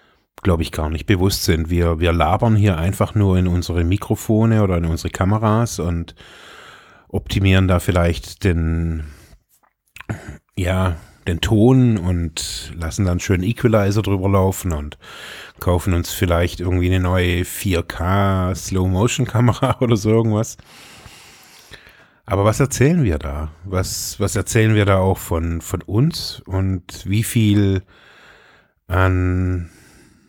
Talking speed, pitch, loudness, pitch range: 125 wpm, 95 Hz, -19 LUFS, 85-105 Hz